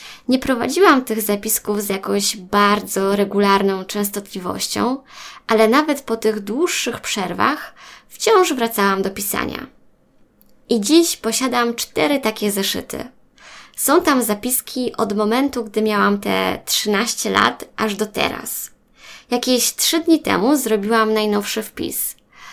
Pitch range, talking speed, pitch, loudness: 205-255 Hz, 120 wpm, 220 Hz, -18 LUFS